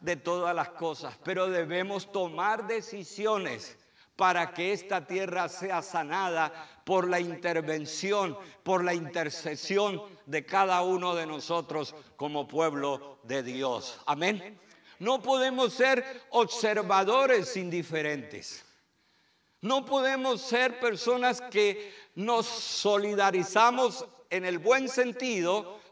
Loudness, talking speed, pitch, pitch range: -29 LUFS, 105 wpm, 190 Hz, 170-235 Hz